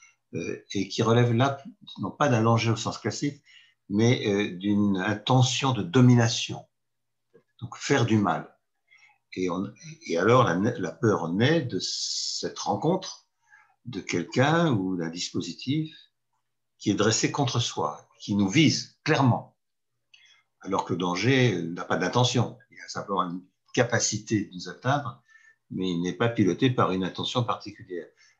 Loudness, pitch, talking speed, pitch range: -26 LUFS, 115 Hz, 145 wpm, 100-135 Hz